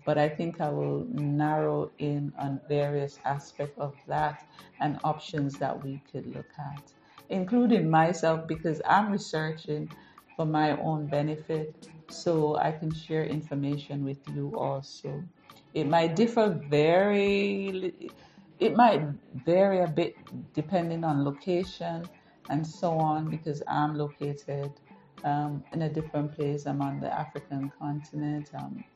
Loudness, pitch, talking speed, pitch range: -29 LUFS, 150 Hz, 135 wpm, 145-165 Hz